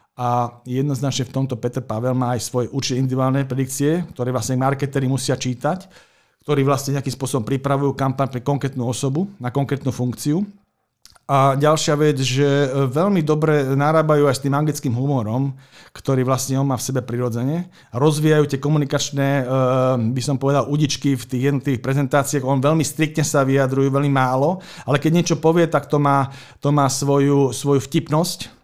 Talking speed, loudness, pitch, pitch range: 160 wpm, -20 LUFS, 140 Hz, 130-145 Hz